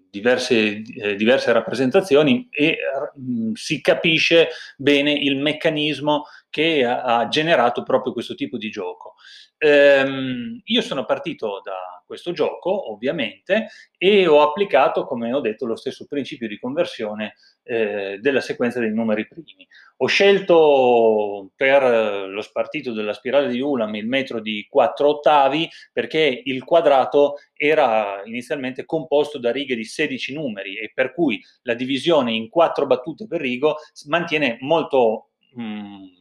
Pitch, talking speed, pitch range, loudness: 140 Hz, 140 wpm, 115-160 Hz, -19 LUFS